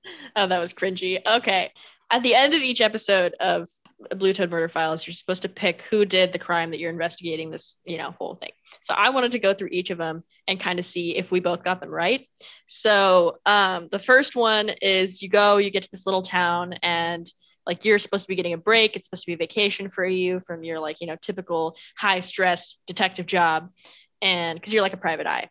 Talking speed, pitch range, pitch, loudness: 235 wpm, 175-200 Hz, 185 Hz, -22 LUFS